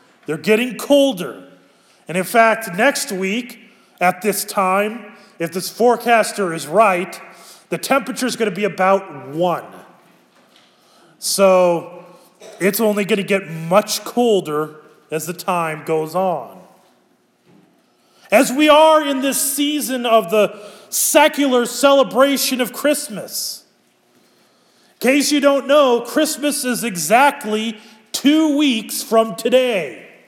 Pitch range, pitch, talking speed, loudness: 190-265 Hz, 220 Hz, 120 wpm, -17 LUFS